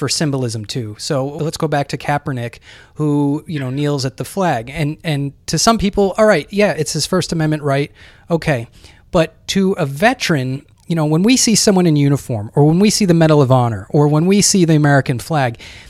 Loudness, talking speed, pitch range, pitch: -15 LUFS, 215 wpm, 135-170 Hz, 150 Hz